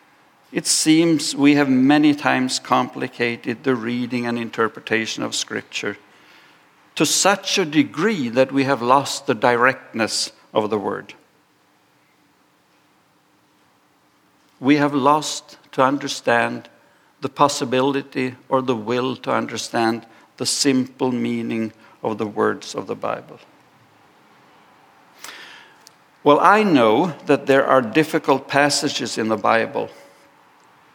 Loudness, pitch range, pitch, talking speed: -19 LUFS, 120-145 Hz, 135 Hz, 110 wpm